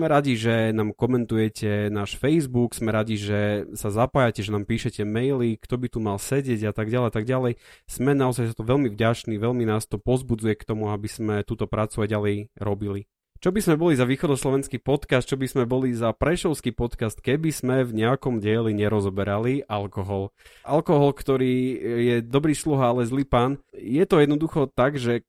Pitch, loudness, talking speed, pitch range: 120 Hz, -24 LUFS, 190 wpm, 105-135 Hz